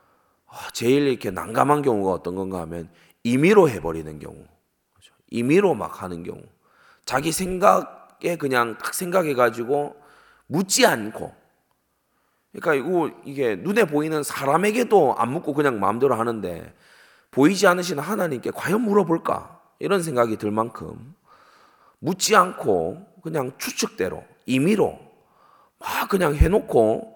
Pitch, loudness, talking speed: 150 Hz, -22 LUFS, 275 characters per minute